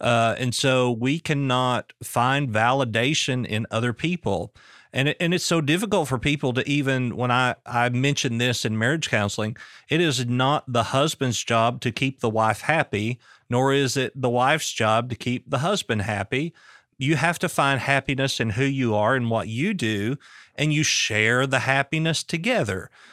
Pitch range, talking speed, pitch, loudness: 120-145 Hz, 180 wpm, 130 Hz, -23 LUFS